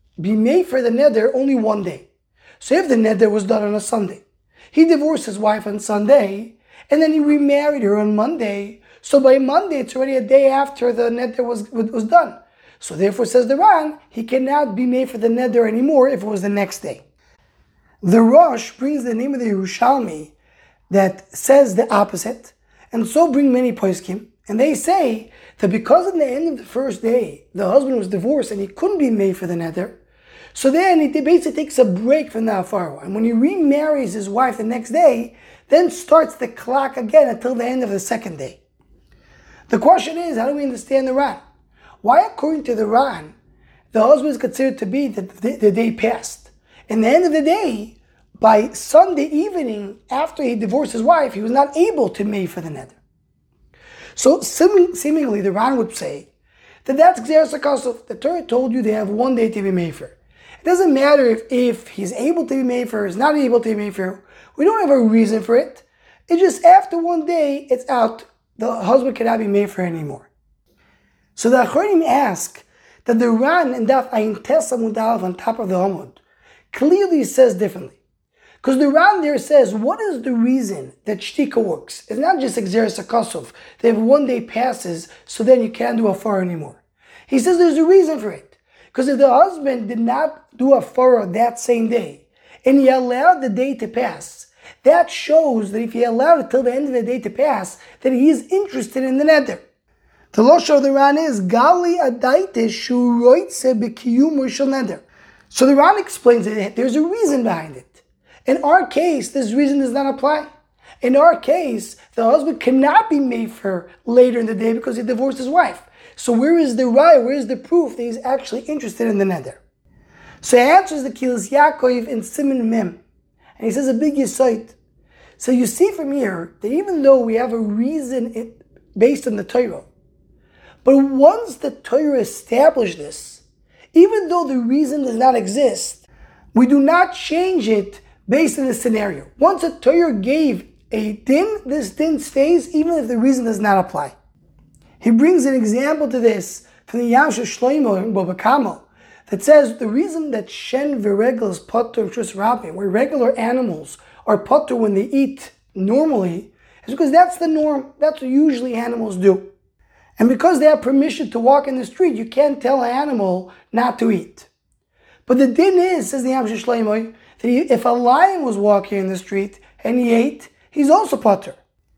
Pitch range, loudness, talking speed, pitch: 225-290 Hz, -17 LUFS, 190 wpm, 255 Hz